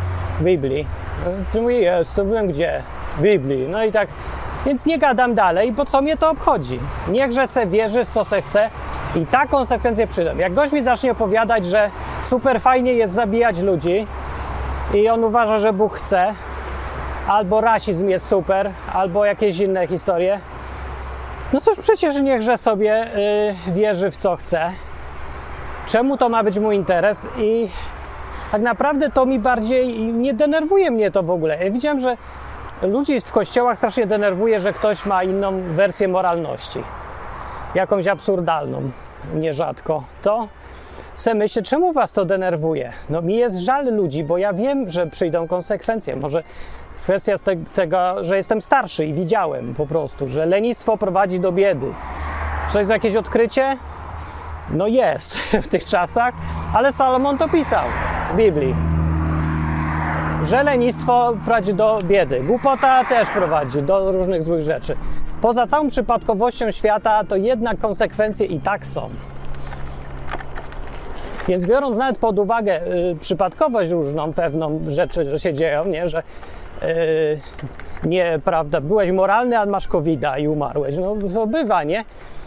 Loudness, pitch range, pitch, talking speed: -19 LUFS, 160-230 Hz, 200 Hz, 145 wpm